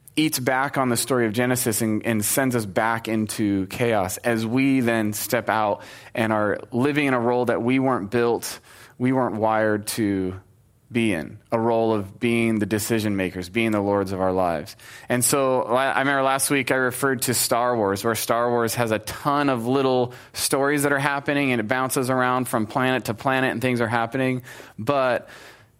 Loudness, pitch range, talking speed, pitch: -22 LUFS, 110-130 Hz, 195 wpm, 120 Hz